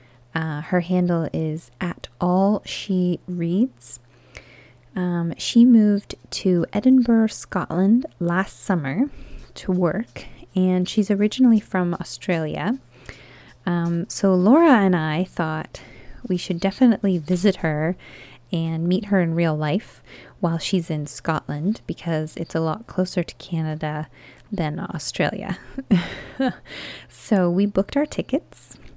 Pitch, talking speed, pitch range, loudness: 180 Hz, 120 wpm, 165-205 Hz, -22 LUFS